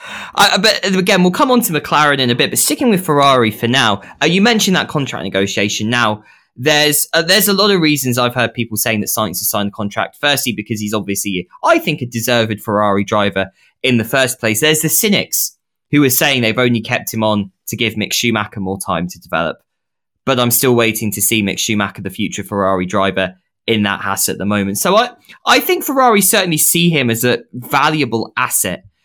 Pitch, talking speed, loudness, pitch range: 120 Hz, 215 wpm, -14 LUFS, 105-155 Hz